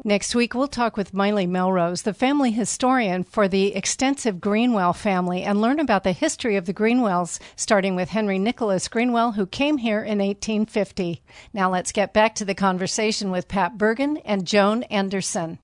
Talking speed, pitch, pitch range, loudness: 175 wpm, 205 Hz, 190-230 Hz, -22 LUFS